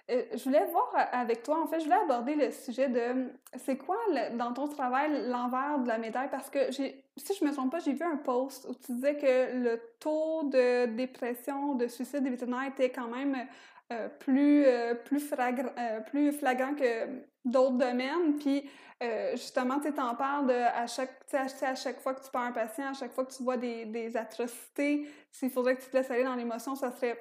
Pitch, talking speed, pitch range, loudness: 260 Hz, 220 wpm, 245-280 Hz, -31 LUFS